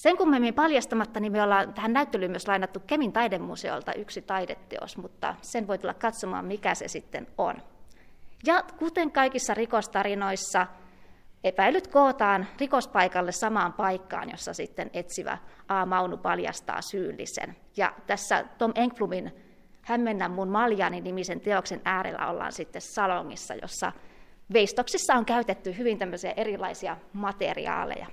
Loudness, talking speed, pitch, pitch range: -28 LUFS, 130 wpm, 205 Hz, 190-240 Hz